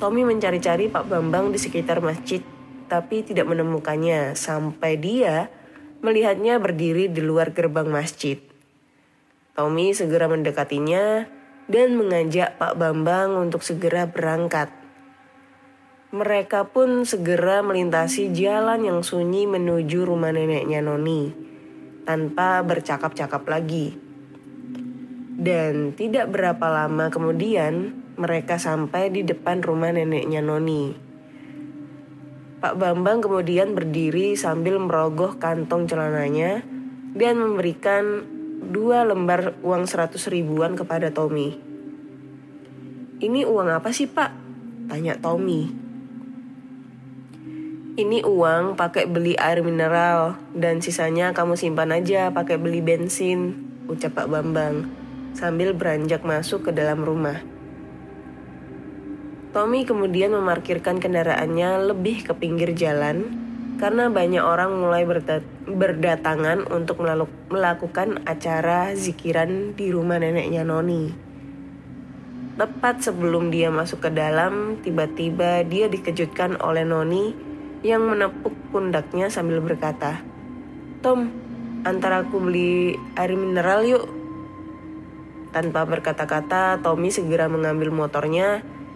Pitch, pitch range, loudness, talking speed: 175 Hz, 160-210 Hz, -22 LUFS, 105 wpm